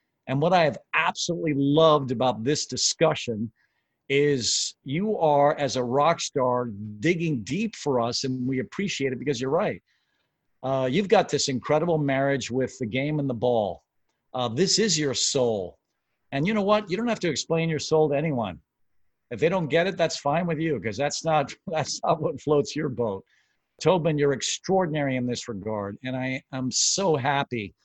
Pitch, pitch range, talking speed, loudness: 140 Hz, 125-160 Hz, 185 wpm, -25 LUFS